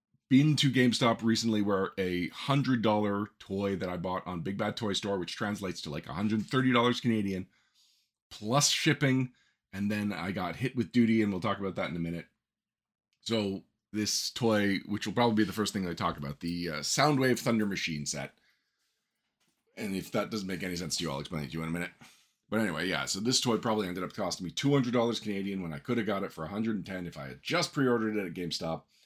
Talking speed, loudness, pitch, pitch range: 215 wpm, -31 LUFS, 105 Hz, 90-120 Hz